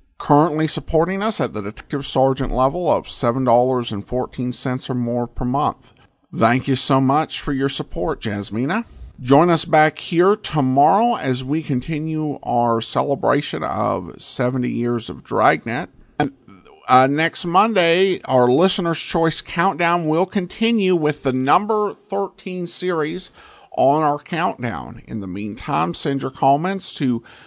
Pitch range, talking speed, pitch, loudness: 125-175 Hz, 135 wpm, 145 Hz, -19 LUFS